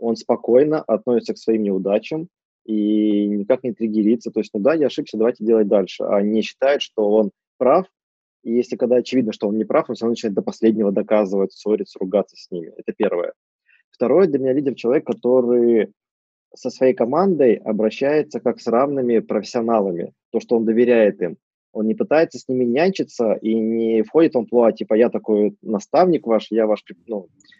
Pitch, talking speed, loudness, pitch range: 115 Hz, 180 wpm, -19 LUFS, 110-130 Hz